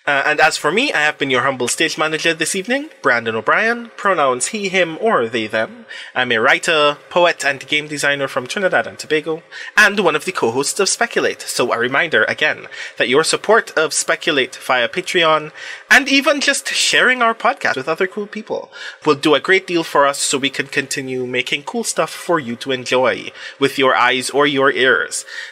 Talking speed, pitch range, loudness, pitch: 200 wpm, 140-215 Hz, -16 LUFS, 160 Hz